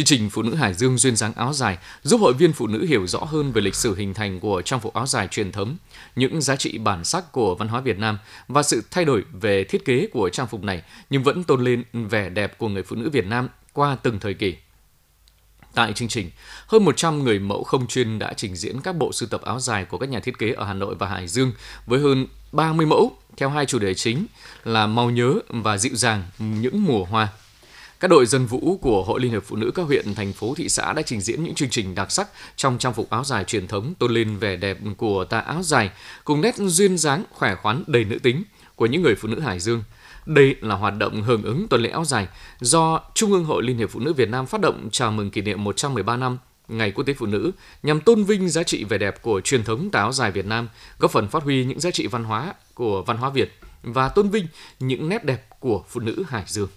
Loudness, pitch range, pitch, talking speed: -22 LUFS, 105-140 Hz, 120 Hz, 255 wpm